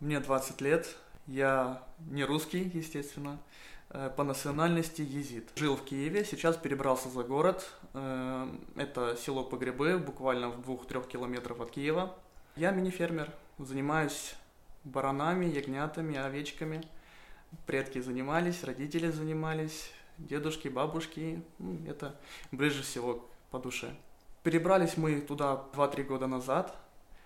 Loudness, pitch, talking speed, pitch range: -34 LUFS, 145 Hz, 110 wpm, 135-160 Hz